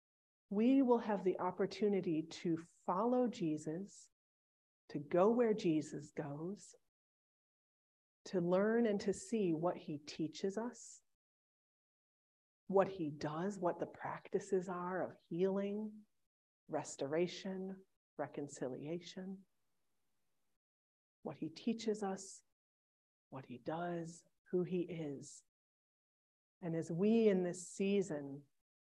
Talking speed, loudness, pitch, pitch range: 100 wpm, -39 LUFS, 180 Hz, 155-195 Hz